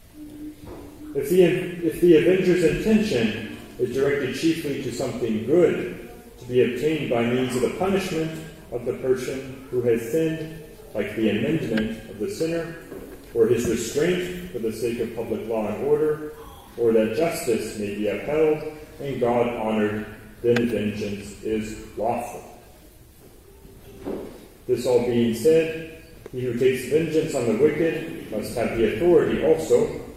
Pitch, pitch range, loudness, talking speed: 155 Hz, 120-175 Hz, -23 LUFS, 145 wpm